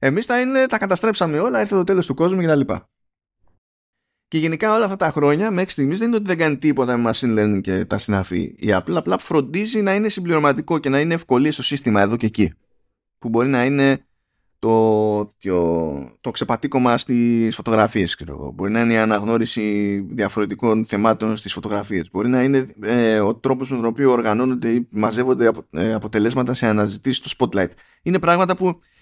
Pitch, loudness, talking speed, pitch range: 120 Hz, -19 LUFS, 190 wpm, 105-150 Hz